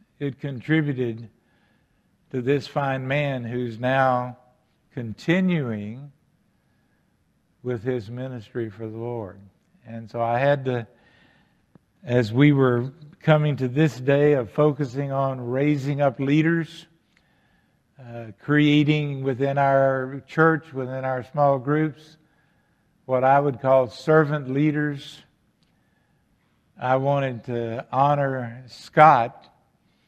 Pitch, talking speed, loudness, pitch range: 135 Hz, 105 wpm, -22 LUFS, 125-150 Hz